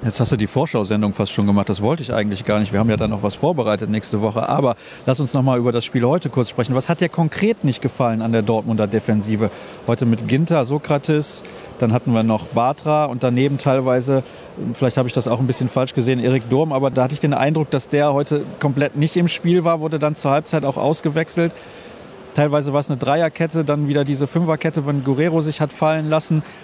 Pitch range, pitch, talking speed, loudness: 120-155 Hz, 135 Hz, 230 wpm, -19 LUFS